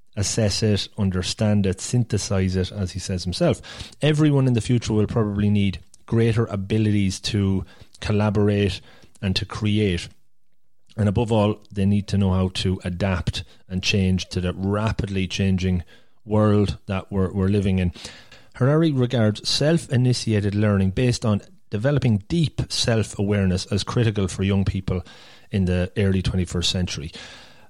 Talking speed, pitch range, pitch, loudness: 140 wpm, 95-110 Hz, 105 Hz, -22 LUFS